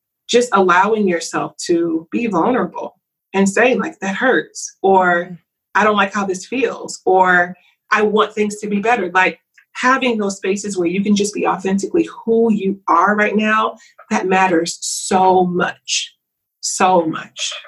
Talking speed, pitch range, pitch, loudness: 155 wpm, 185-230 Hz, 200 Hz, -16 LUFS